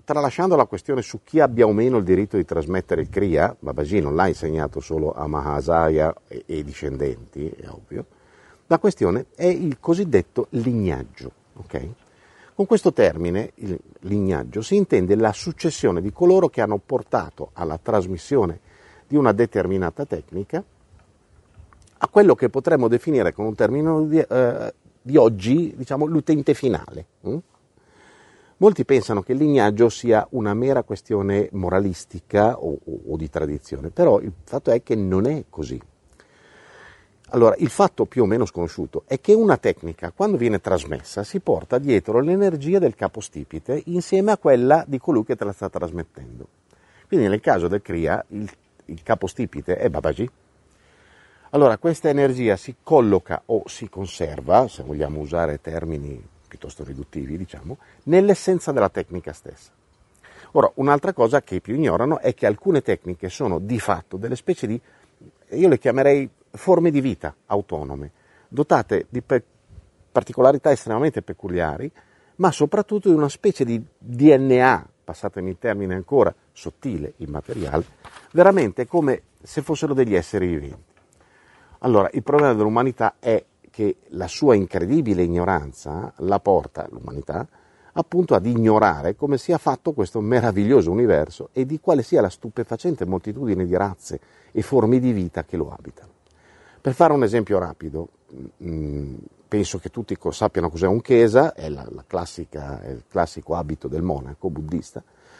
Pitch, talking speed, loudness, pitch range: 110 Hz, 150 wpm, -21 LUFS, 90-140 Hz